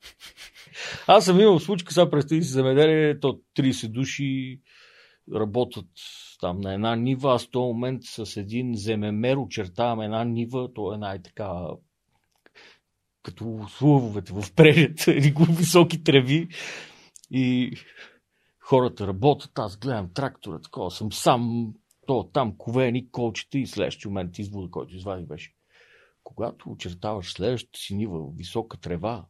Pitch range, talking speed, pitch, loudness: 105-140 Hz, 125 wpm, 120 Hz, -24 LUFS